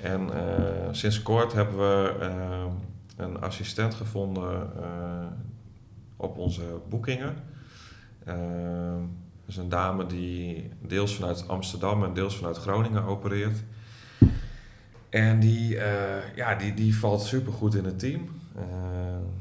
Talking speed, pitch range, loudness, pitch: 125 wpm, 90-110 Hz, -29 LUFS, 100 Hz